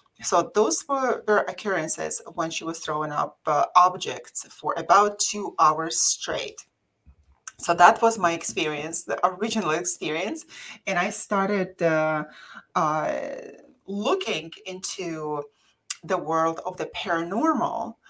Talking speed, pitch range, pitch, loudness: 125 wpm, 160-210 Hz, 180 Hz, -24 LUFS